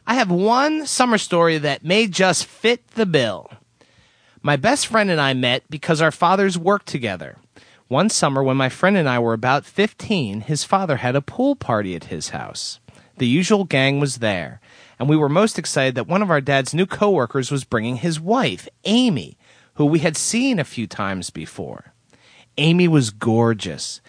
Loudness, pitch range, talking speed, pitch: -19 LUFS, 130-195 Hz, 185 wpm, 155 Hz